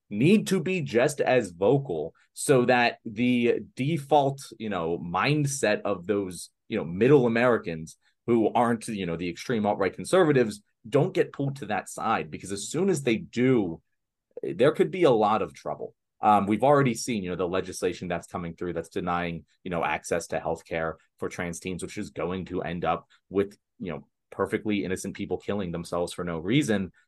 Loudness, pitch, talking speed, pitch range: -26 LUFS, 105 Hz, 190 wpm, 90-125 Hz